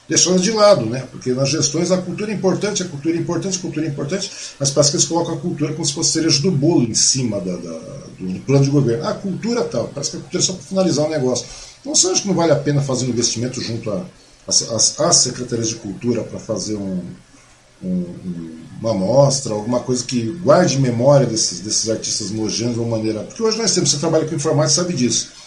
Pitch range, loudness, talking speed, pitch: 115-175 Hz, -17 LUFS, 245 wpm, 145 Hz